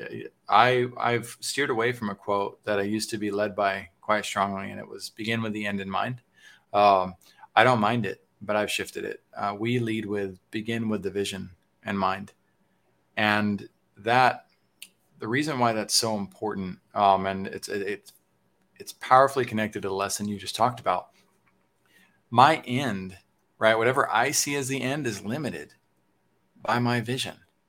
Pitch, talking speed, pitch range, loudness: 105 Hz, 175 wpm, 100-115 Hz, -26 LUFS